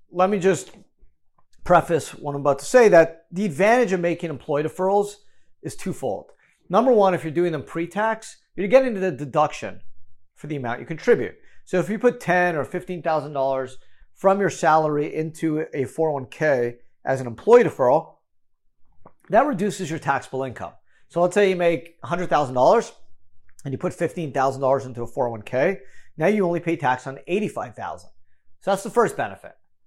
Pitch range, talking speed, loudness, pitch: 130-185 Hz, 165 wpm, -22 LUFS, 160 Hz